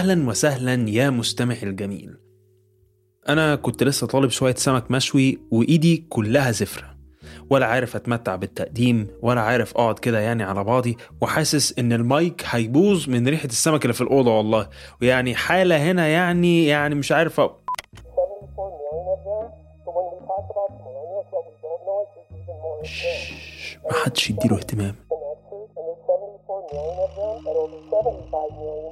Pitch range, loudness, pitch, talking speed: 115-165 Hz, -22 LUFS, 135 Hz, 100 wpm